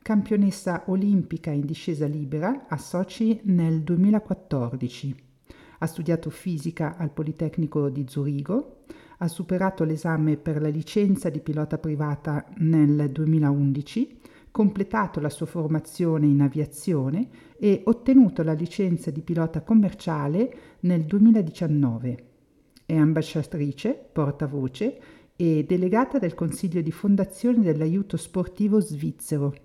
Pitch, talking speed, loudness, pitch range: 165 Hz, 110 wpm, -24 LUFS, 150-195 Hz